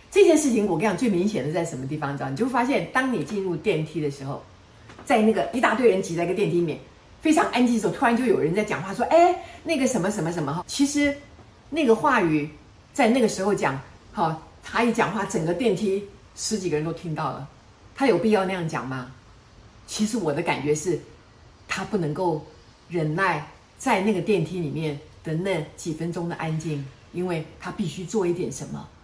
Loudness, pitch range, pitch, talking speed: -24 LUFS, 150-220 Hz, 175 Hz, 305 characters per minute